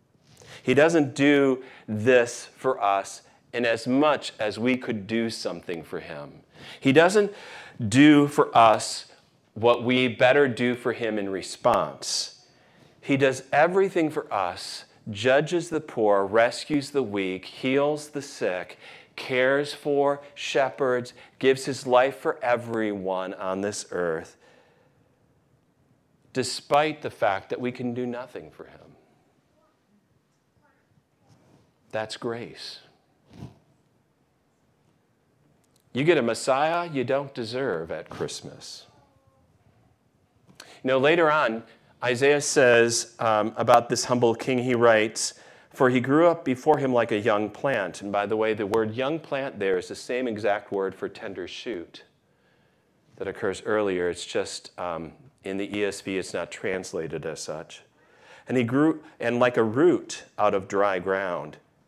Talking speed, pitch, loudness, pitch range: 135 wpm, 125 Hz, -24 LUFS, 110-140 Hz